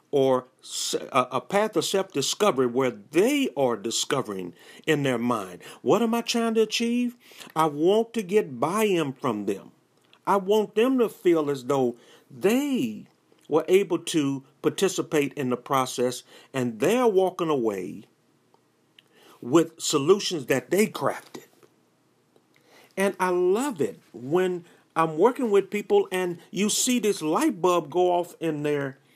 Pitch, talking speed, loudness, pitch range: 175 Hz, 145 wpm, -25 LUFS, 140-210 Hz